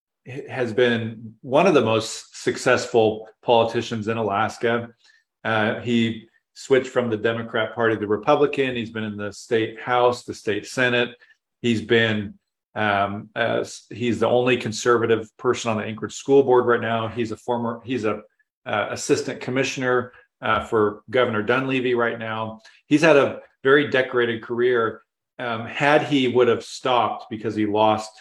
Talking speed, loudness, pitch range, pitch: 155 wpm, -22 LUFS, 110-125 Hz, 115 Hz